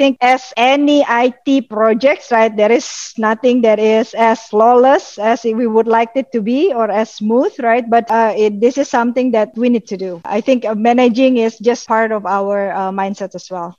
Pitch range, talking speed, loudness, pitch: 215-250 Hz, 215 wpm, -14 LUFS, 230 Hz